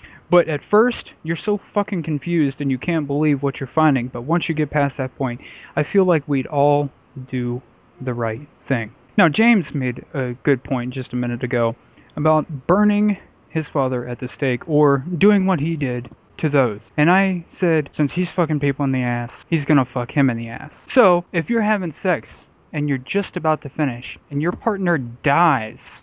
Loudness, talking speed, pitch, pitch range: -20 LUFS, 200 wpm, 145 Hz, 125-170 Hz